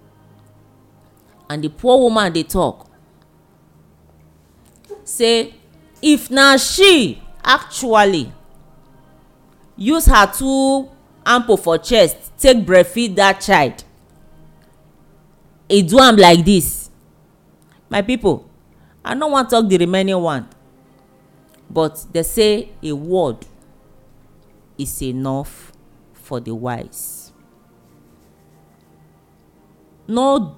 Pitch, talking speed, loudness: 175 Hz, 90 wpm, -15 LUFS